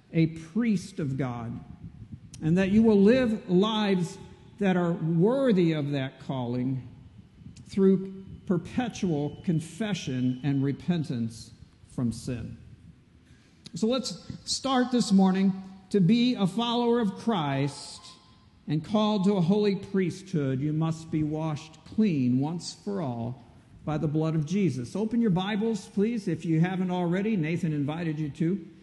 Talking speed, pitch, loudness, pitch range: 135 wpm, 170 Hz, -27 LUFS, 145-200 Hz